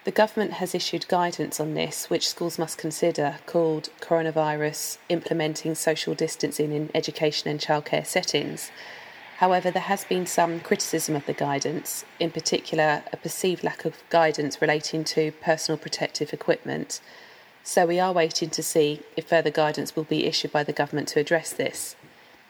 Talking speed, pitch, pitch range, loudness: 160 wpm, 160 Hz, 150-170 Hz, -25 LUFS